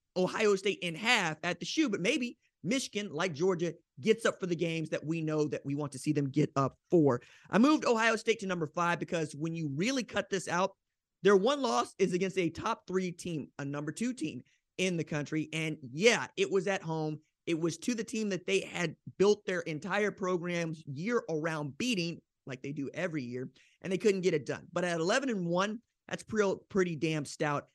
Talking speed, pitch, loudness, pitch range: 215 wpm, 175 Hz, -32 LUFS, 155-200 Hz